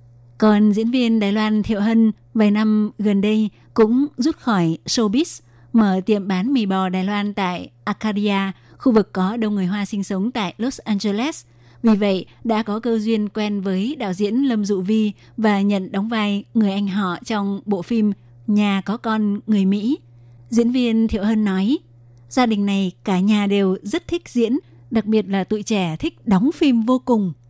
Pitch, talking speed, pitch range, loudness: 210 Hz, 190 wpm, 195-225 Hz, -20 LUFS